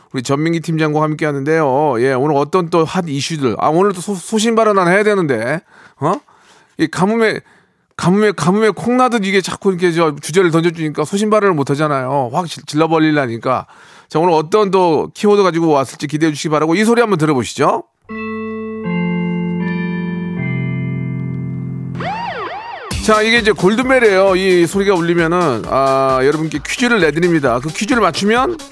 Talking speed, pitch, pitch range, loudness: 325 characters per minute, 175 Hz, 155-205 Hz, -15 LUFS